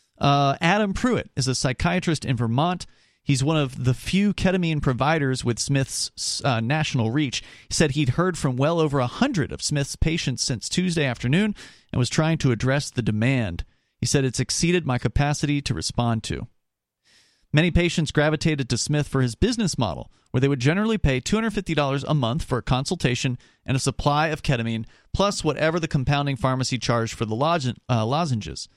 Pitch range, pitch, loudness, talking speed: 125-160 Hz, 140 Hz, -23 LUFS, 190 wpm